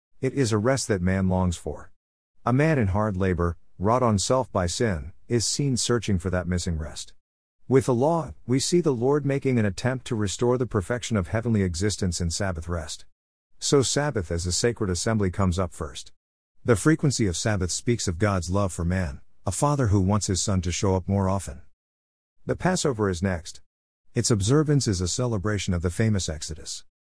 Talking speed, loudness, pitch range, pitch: 195 wpm, -25 LUFS, 90-120 Hz, 100 Hz